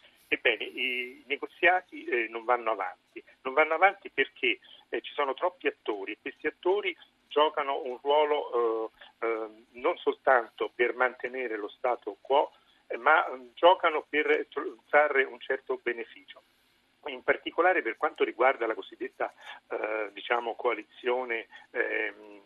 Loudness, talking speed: -29 LUFS, 115 wpm